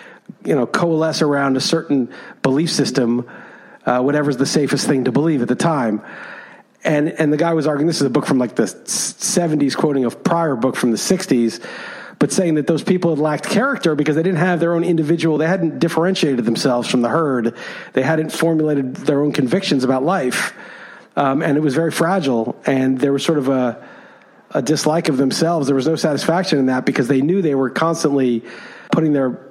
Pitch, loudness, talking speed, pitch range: 150 Hz, -17 LUFS, 200 wpm, 135-165 Hz